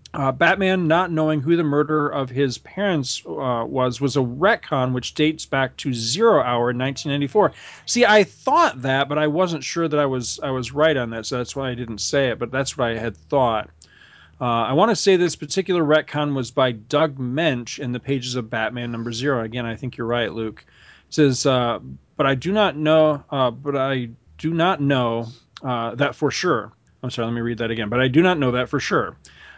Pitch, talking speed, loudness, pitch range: 135 Hz, 225 wpm, -21 LUFS, 120-155 Hz